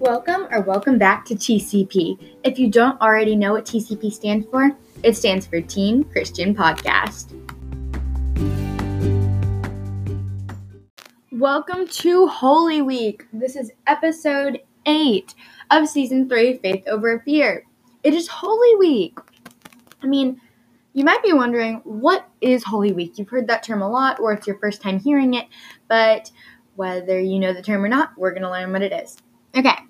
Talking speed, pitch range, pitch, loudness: 155 wpm, 190-275 Hz, 225 Hz, -19 LUFS